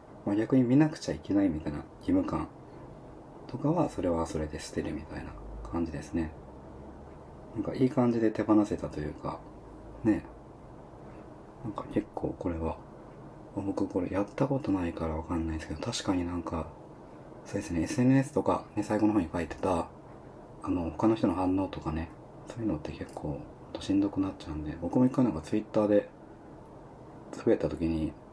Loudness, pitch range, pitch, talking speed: -31 LUFS, 80-125 Hz, 90 Hz, 340 characters per minute